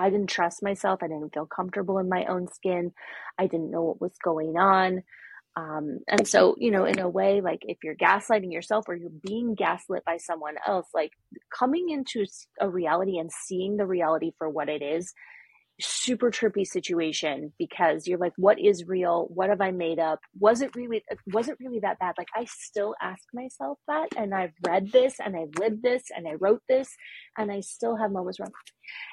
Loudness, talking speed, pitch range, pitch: -27 LUFS, 200 wpm, 170-215 Hz, 190 Hz